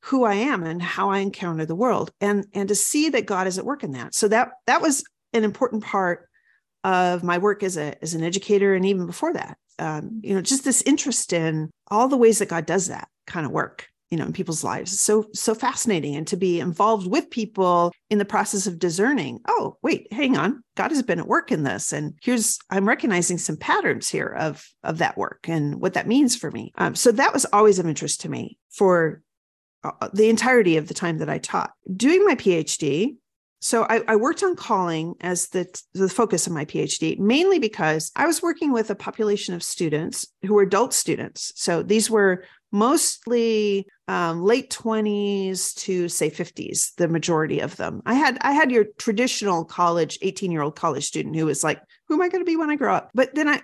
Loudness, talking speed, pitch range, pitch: -22 LUFS, 215 wpm, 175-240 Hz, 205 Hz